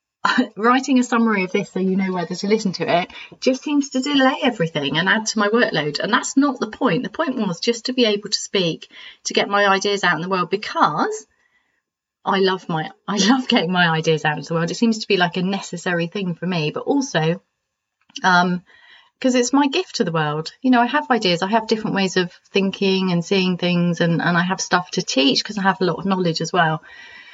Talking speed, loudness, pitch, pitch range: 240 wpm, -19 LUFS, 195 Hz, 175-240 Hz